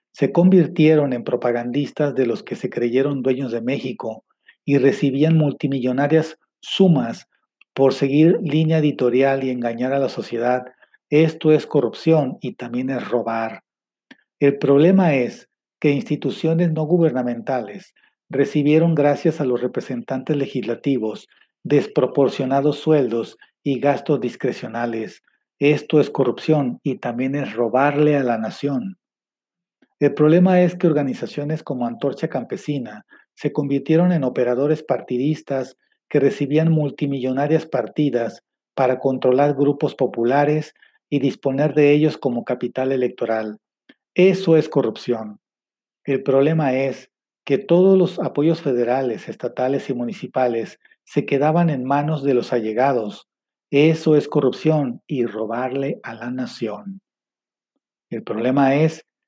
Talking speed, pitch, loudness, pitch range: 120 wpm, 140 Hz, -20 LUFS, 125-155 Hz